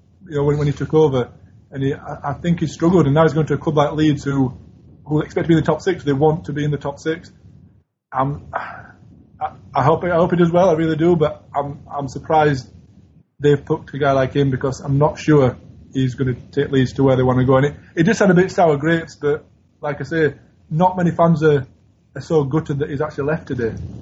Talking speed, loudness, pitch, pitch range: 245 wpm, -18 LUFS, 145 Hz, 135-160 Hz